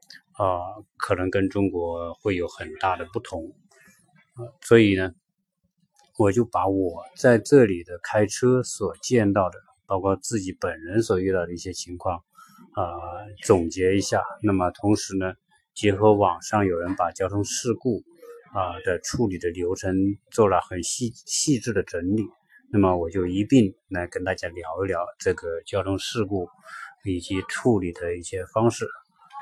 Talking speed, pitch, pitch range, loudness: 230 characters per minute, 100 Hz, 95-120 Hz, -24 LUFS